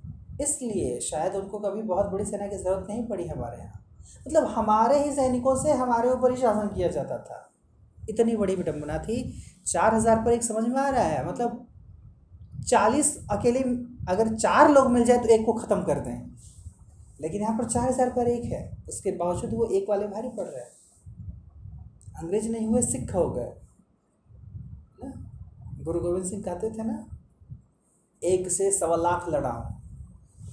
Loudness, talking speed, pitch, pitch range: -25 LUFS, 170 wpm, 205 Hz, 155-235 Hz